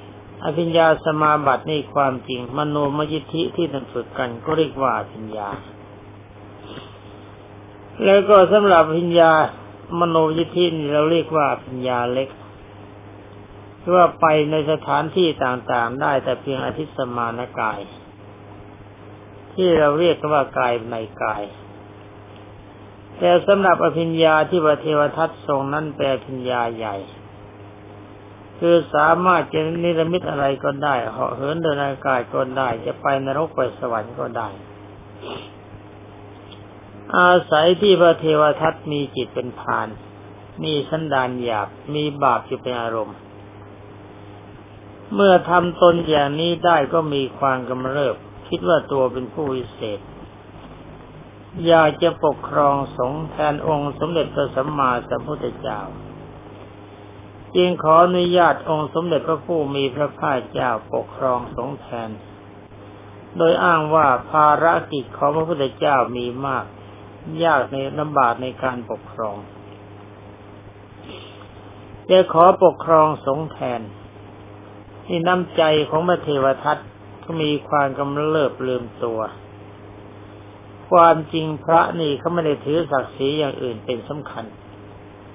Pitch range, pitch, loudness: 105-155 Hz, 130 Hz, -19 LUFS